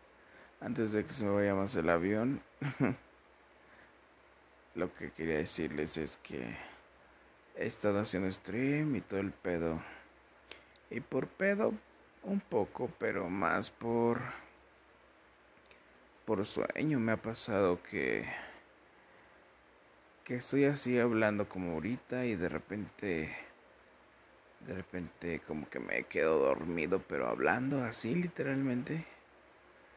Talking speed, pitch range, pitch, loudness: 115 wpm, 90-130 Hz, 110 Hz, -35 LUFS